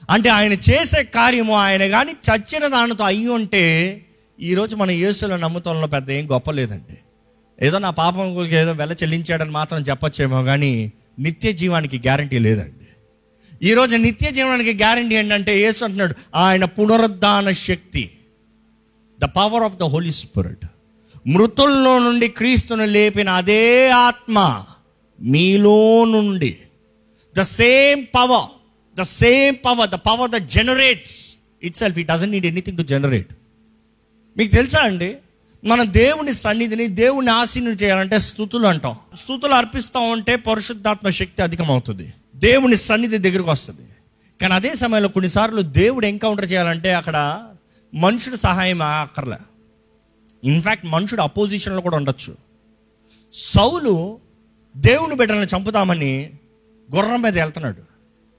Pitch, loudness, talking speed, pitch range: 190 Hz, -16 LUFS, 120 wpm, 150-225 Hz